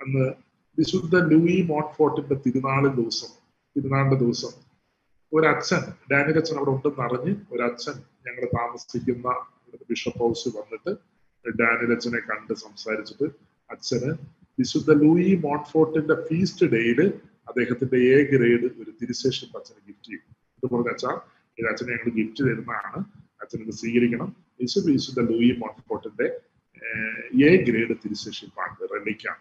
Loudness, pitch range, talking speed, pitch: -24 LUFS, 120-160 Hz, 110 wpm, 135 Hz